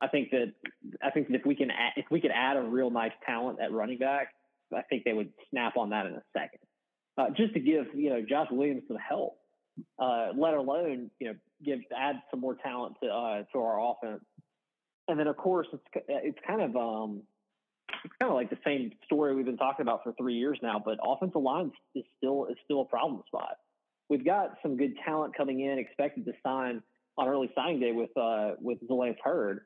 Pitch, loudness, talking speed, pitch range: 135 Hz, -32 LUFS, 225 wpm, 125-145 Hz